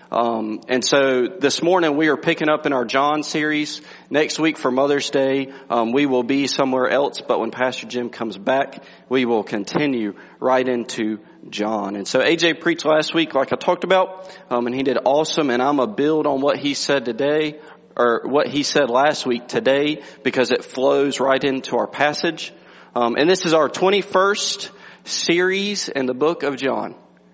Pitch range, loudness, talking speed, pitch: 125-155 Hz, -20 LUFS, 185 wpm, 140 Hz